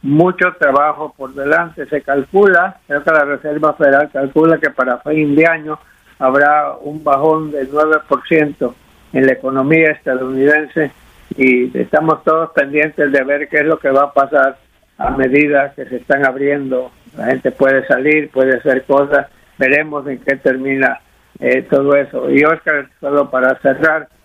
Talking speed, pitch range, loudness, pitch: 160 wpm, 135-155 Hz, -14 LUFS, 145 Hz